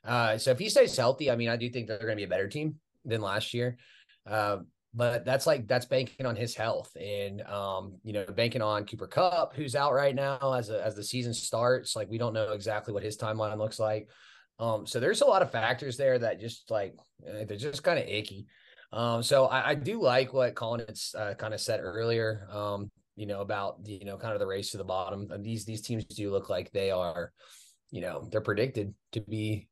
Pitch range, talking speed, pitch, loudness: 105-120 Hz, 235 wpm, 110 Hz, -31 LUFS